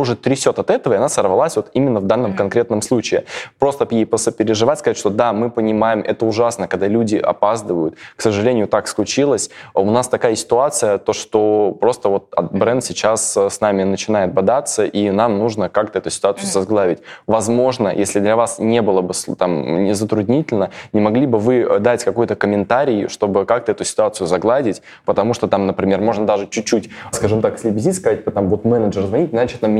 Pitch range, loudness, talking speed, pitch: 100-115 Hz, -17 LUFS, 180 wpm, 110 Hz